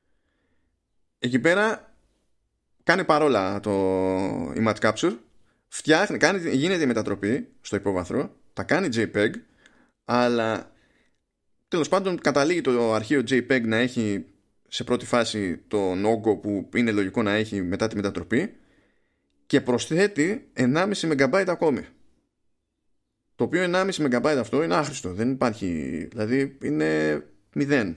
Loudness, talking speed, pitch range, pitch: -24 LUFS, 120 wpm, 100-135 Hz, 115 Hz